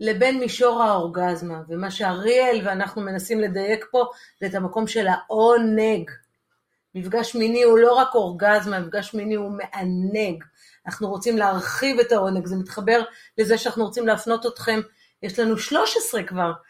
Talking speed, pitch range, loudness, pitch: 145 wpm, 195-230 Hz, -22 LUFS, 215 Hz